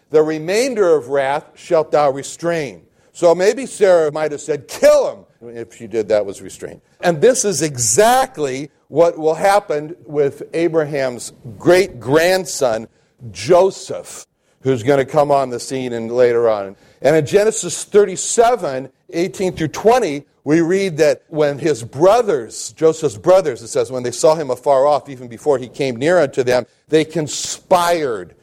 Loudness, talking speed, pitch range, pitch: -16 LUFS, 155 wpm, 130-180 Hz, 155 Hz